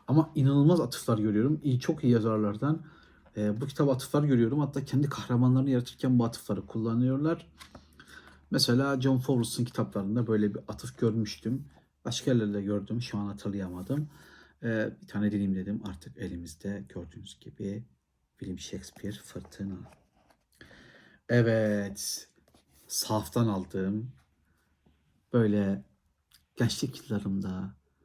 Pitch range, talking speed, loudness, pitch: 100-130 Hz, 110 wpm, -30 LUFS, 110 Hz